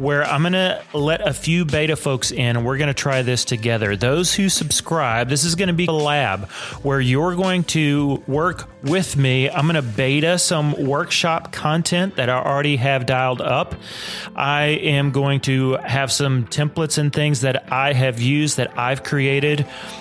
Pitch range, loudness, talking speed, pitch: 130-155 Hz, -19 LUFS, 175 wpm, 140 Hz